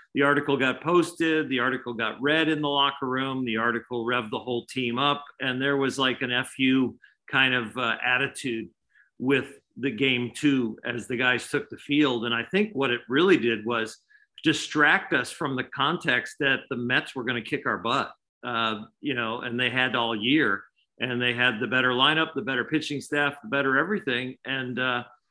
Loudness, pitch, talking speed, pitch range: -25 LUFS, 130 Hz, 200 wpm, 120-140 Hz